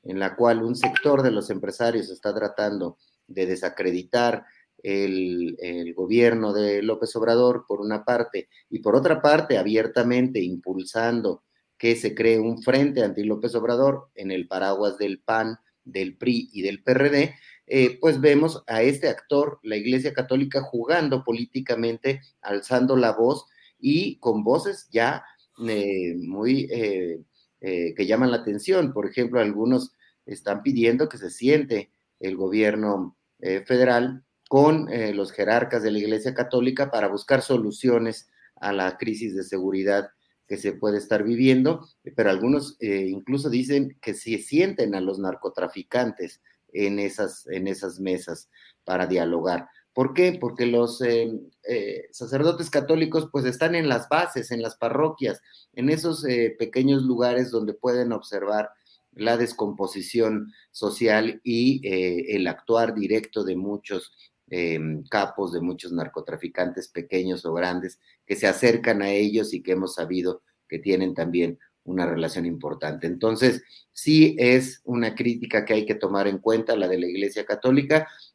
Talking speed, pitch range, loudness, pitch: 150 wpm, 95-130 Hz, -24 LUFS, 115 Hz